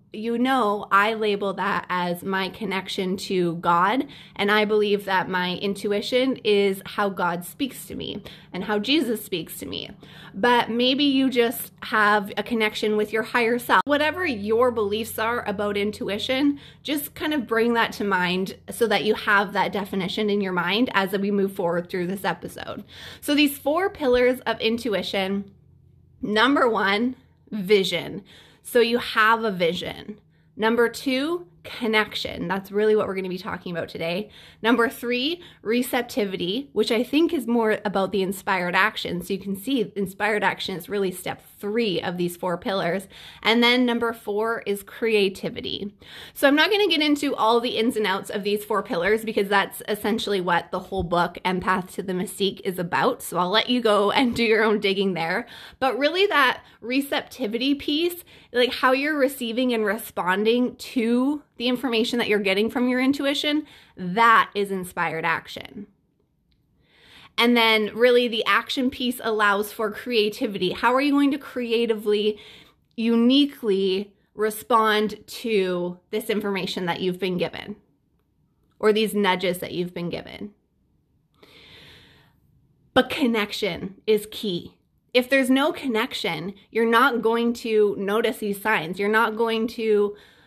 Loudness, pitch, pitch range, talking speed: -23 LUFS, 215 Hz, 195-240 Hz, 160 wpm